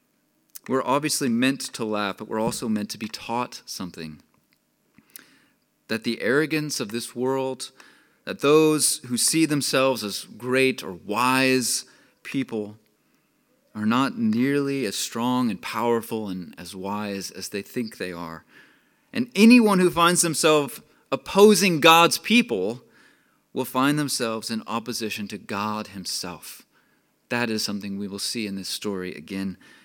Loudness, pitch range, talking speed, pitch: -23 LUFS, 105-155 Hz, 140 wpm, 125 Hz